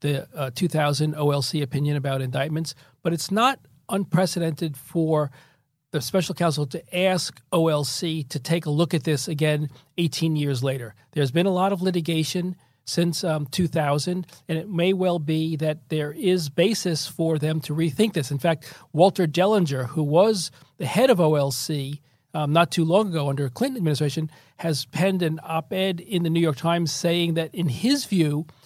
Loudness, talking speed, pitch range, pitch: -24 LUFS, 180 wpm, 145-175 Hz, 160 Hz